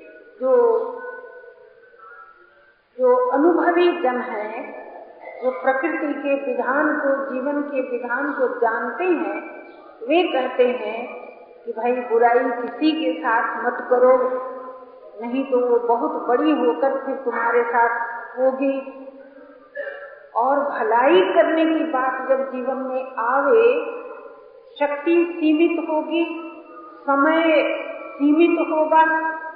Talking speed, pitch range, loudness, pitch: 100 wpm, 250-325 Hz, -20 LUFS, 280 Hz